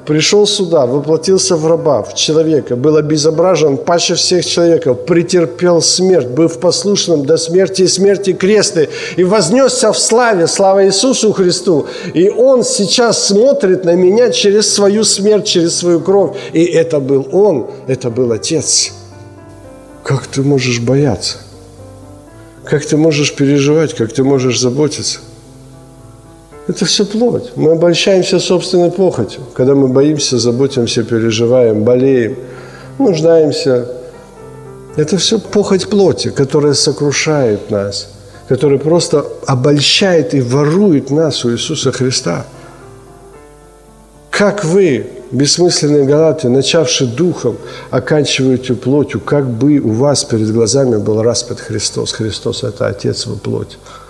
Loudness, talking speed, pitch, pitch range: -11 LUFS, 125 wpm, 150 Hz, 125-180 Hz